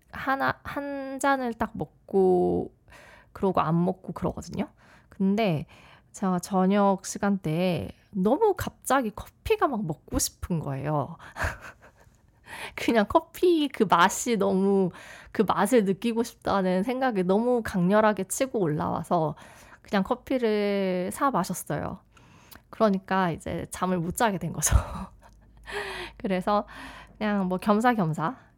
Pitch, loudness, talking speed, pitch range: 195 Hz, -26 LUFS, 235 characters per minute, 180-235 Hz